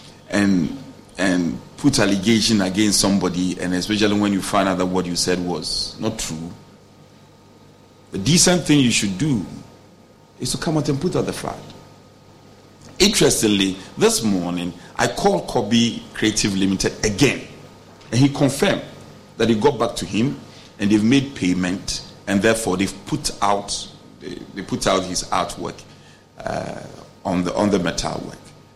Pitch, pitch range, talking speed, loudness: 100 Hz, 90-115 Hz, 150 wpm, -20 LUFS